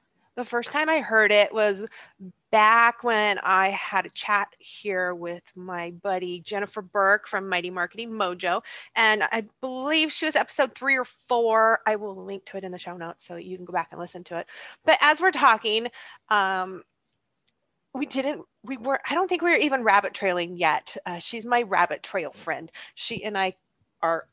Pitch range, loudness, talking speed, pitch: 185-240 Hz, -24 LUFS, 190 wpm, 210 Hz